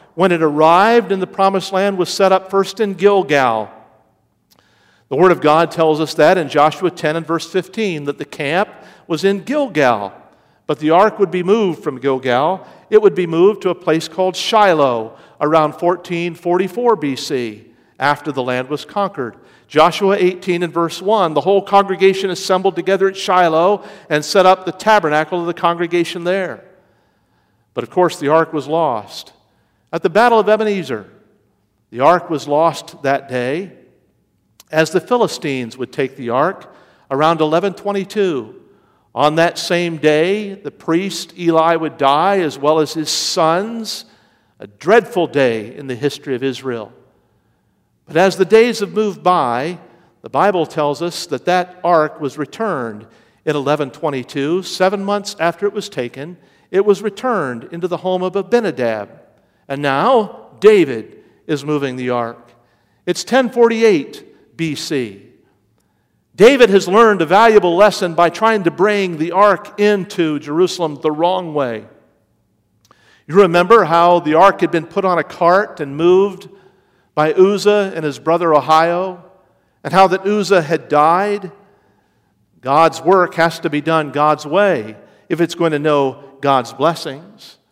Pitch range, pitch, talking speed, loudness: 150-195 Hz, 175 Hz, 155 wpm, -15 LUFS